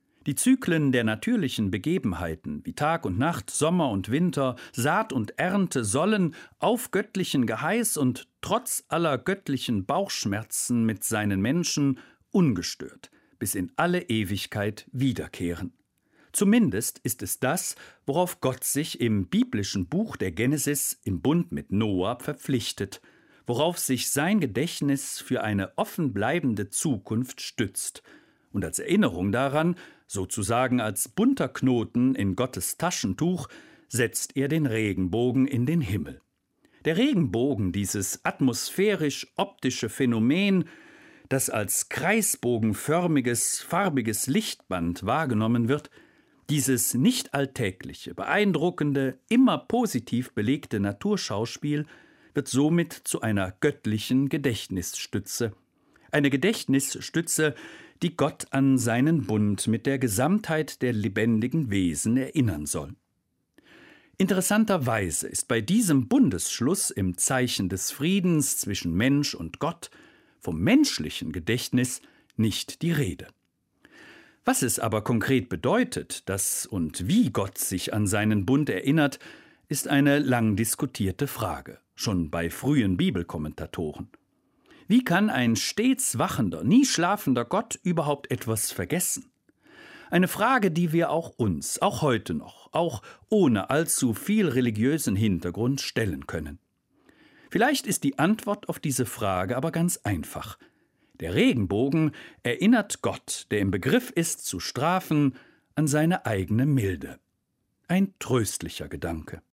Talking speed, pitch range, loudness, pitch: 120 wpm, 110-165 Hz, -26 LUFS, 130 Hz